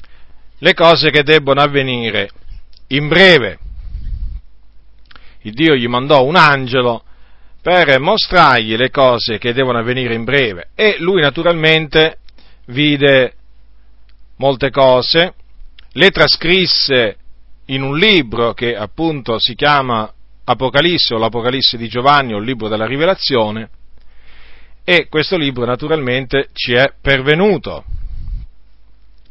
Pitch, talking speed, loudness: 125 Hz, 110 wpm, -12 LUFS